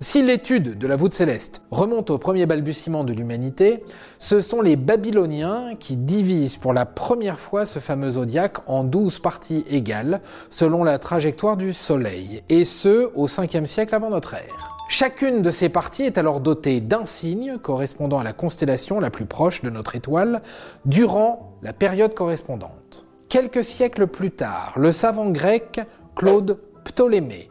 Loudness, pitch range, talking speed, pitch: -21 LUFS, 145-220 Hz, 160 wpm, 175 Hz